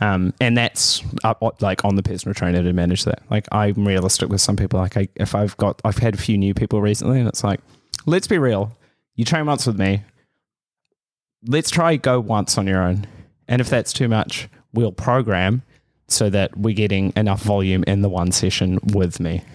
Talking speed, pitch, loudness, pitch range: 205 wpm, 105 Hz, -19 LUFS, 95-120 Hz